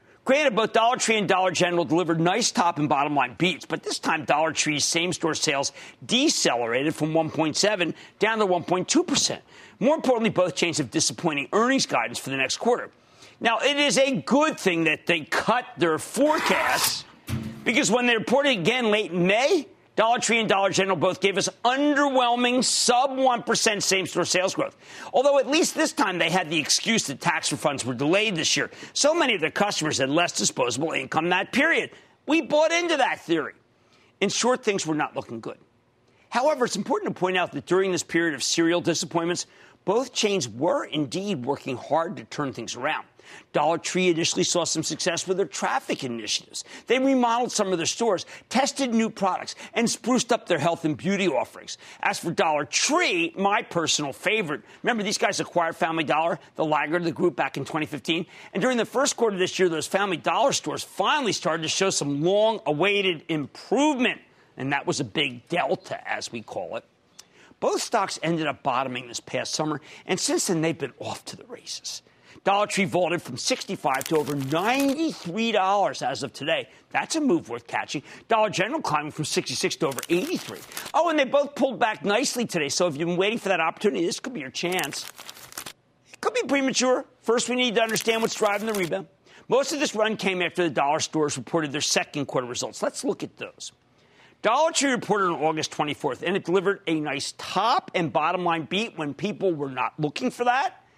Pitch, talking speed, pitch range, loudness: 185 Hz, 195 wpm, 160-235 Hz, -24 LUFS